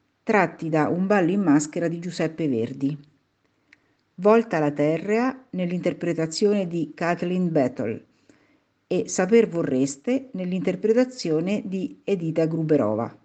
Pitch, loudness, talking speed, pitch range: 170 Hz, -23 LUFS, 105 wpm, 155-200 Hz